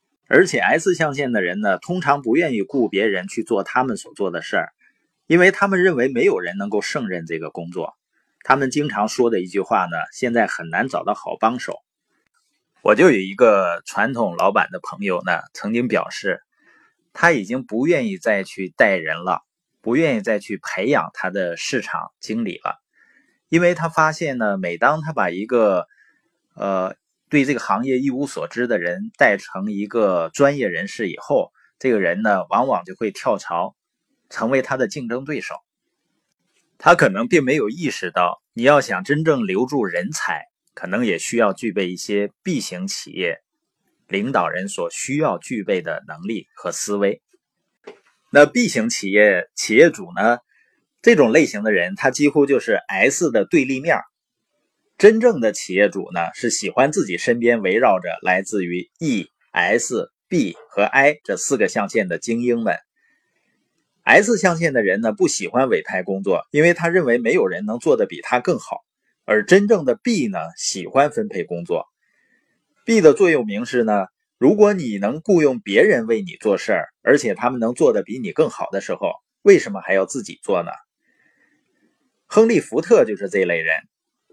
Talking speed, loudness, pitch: 250 characters per minute, -19 LUFS, 145 Hz